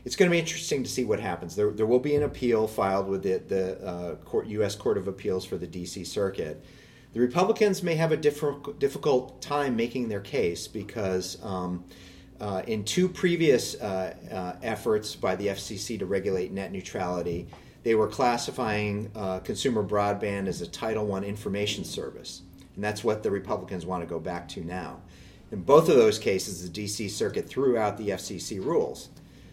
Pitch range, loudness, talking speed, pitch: 95-125 Hz, -28 LUFS, 185 wpm, 105 Hz